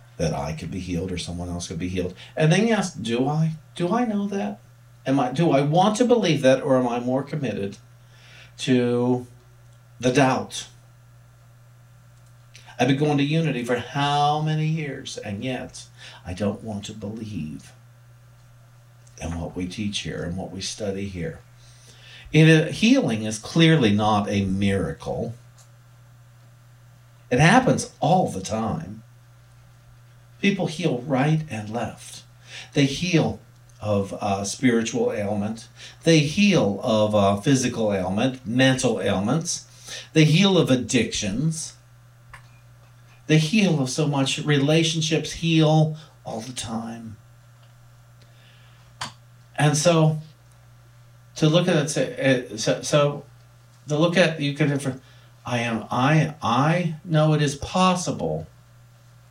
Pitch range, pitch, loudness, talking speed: 120-145 Hz, 120 Hz, -22 LUFS, 130 wpm